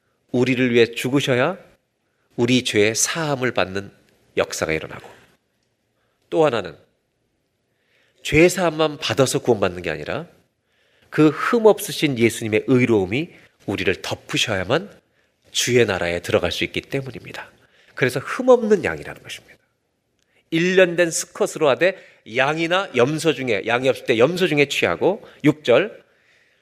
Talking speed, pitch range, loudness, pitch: 280 characters per minute, 120-165 Hz, -20 LUFS, 135 Hz